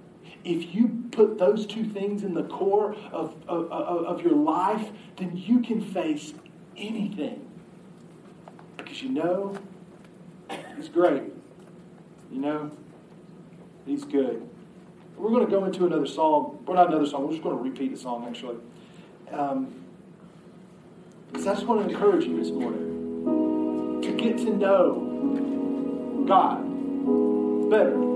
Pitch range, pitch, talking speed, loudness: 155-215 Hz, 185 Hz, 135 wpm, -26 LUFS